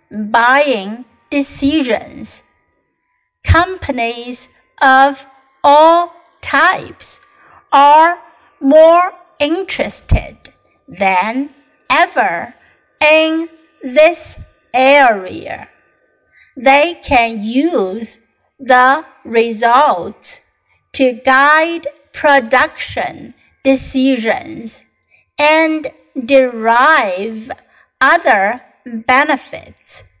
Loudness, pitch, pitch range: -12 LUFS, 275 Hz, 250-310 Hz